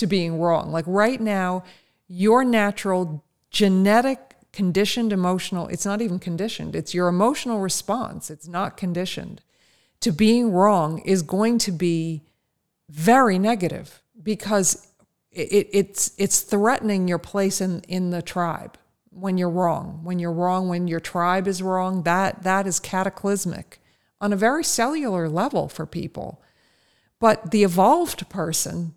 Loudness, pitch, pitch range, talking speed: -22 LUFS, 190 Hz, 175-205 Hz, 140 wpm